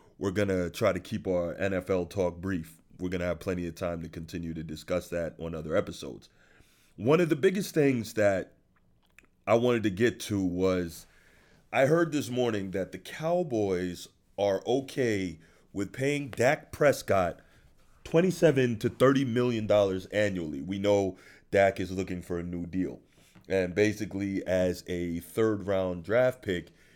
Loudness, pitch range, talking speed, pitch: -29 LUFS, 90-115 Hz, 160 wpm, 95 Hz